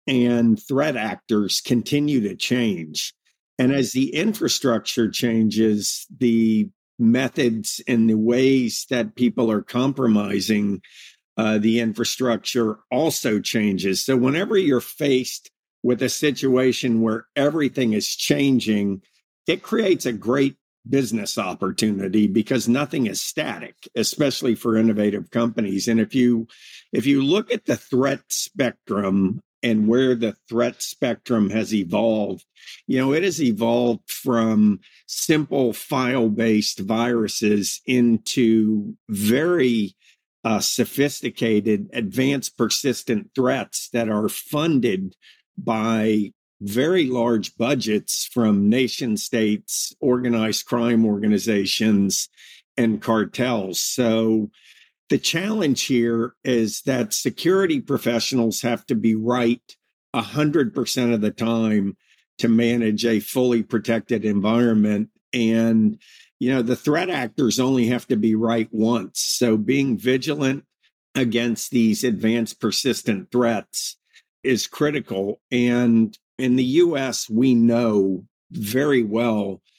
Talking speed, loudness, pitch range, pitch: 115 wpm, -21 LUFS, 110-125 Hz, 115 Hz